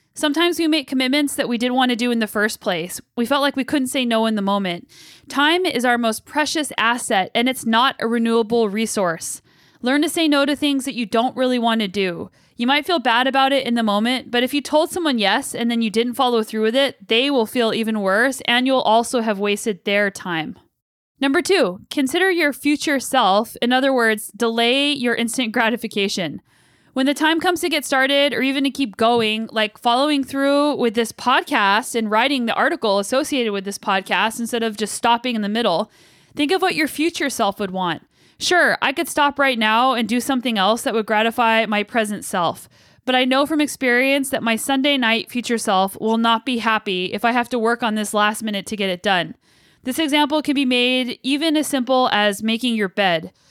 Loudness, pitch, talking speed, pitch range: -19 LUFS, 240 Hz, 220 wpm, 220-275 Hz